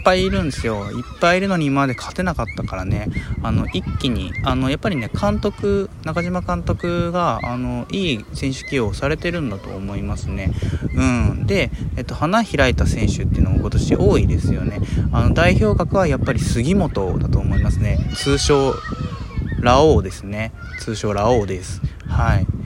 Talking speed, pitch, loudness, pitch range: 345 characters per minute, 115 Hz, -20 LUFS, 100-140 Hz